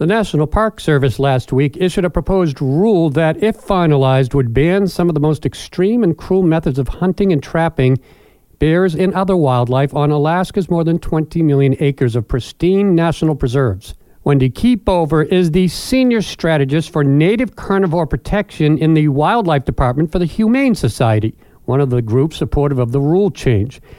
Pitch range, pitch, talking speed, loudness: 140-185 Hz, 155 Hz, 175 wpm, -15 LUFS